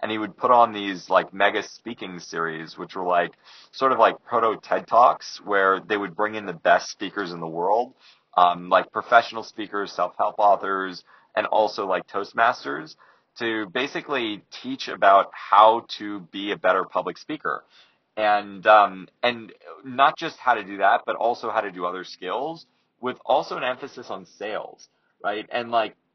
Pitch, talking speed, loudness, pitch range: 105 Hz, 175 wpm, -23 LUFS, 95-120 Hz